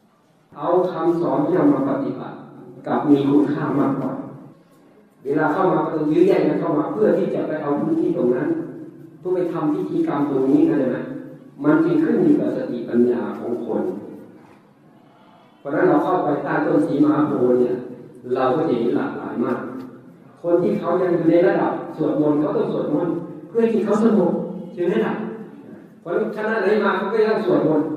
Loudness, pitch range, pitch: -20 LUFS, 155-220 Hz, 175 Hz